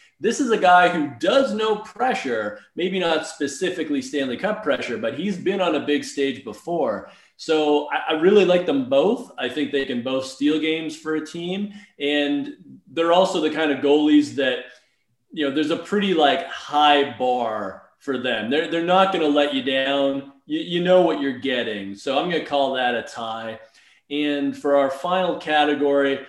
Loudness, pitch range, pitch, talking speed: -21 LUFS, 140-175 Hz, 150 Hz, 185 wpm